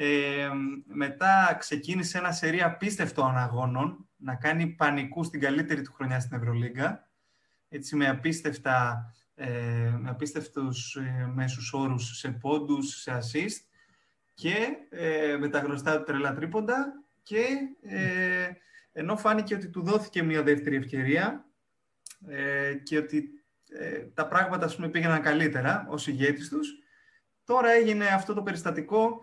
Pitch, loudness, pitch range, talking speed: 150 Hz, -28 LUFS, 135-185 Hz, 115 wpm